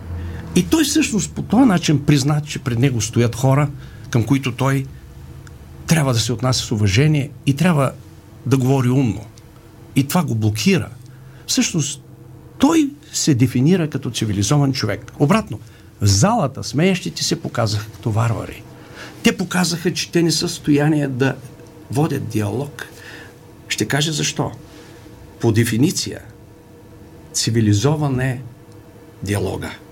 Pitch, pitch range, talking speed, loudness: 135 Hz, 115-150 Hz, 130 wpm, -18 LUFS